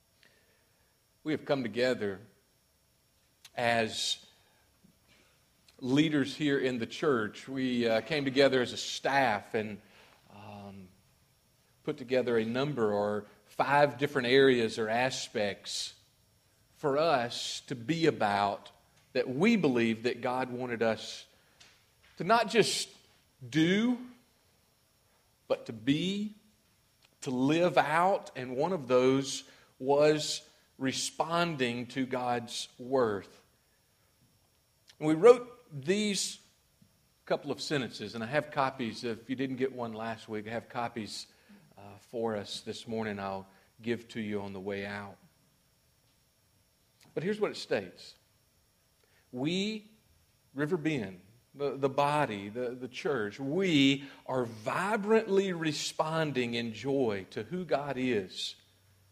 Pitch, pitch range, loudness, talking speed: 125 Hz, 110-145 Hz, -31 LUFS, 120 wpm